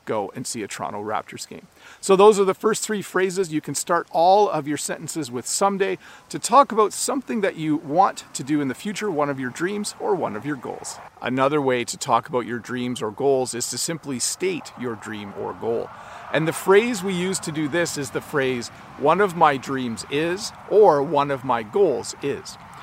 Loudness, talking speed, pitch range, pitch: -22 LUFS, 220 wpm, 130-195 Hz, 155 Hz